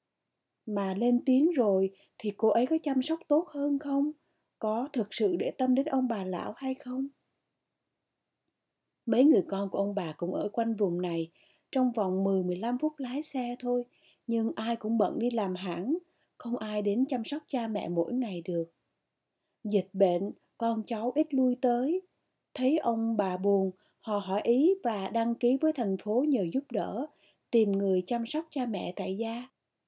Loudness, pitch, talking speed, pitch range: -30 LUFS, 230 Hz, 180 wpm, 200-265 Hz